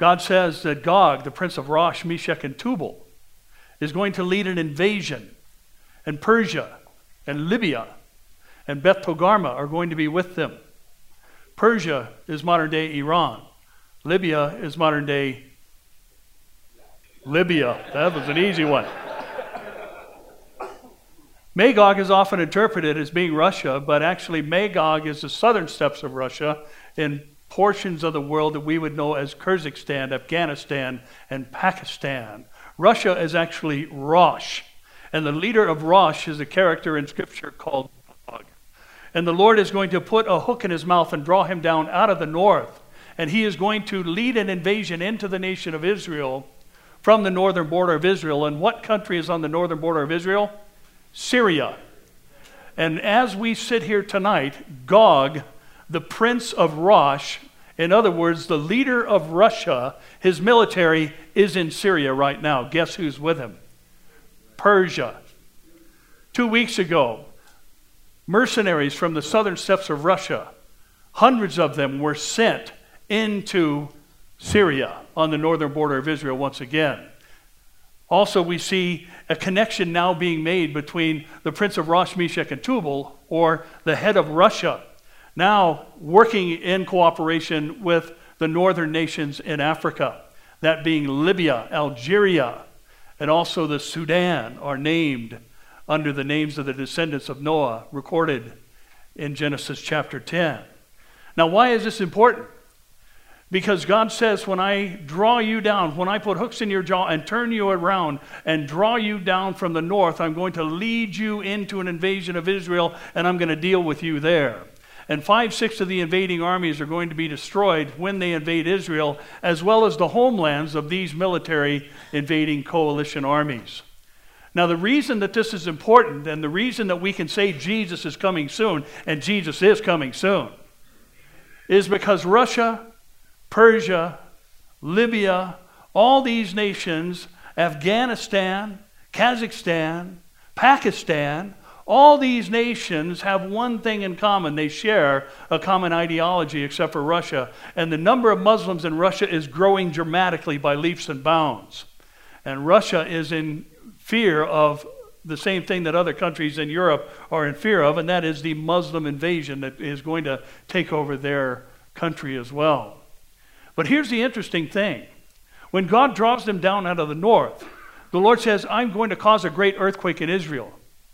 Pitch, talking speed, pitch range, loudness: 170 Hz, 155 wpm, 150-195 Hz, -21 LUFS